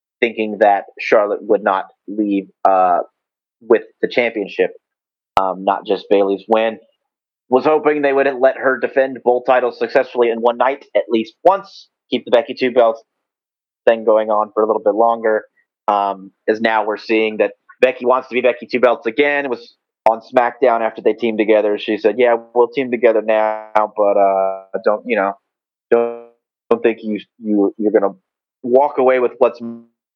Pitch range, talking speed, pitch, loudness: 110-130 Hz, 175 wpm, 115 Hz, -16 LUFS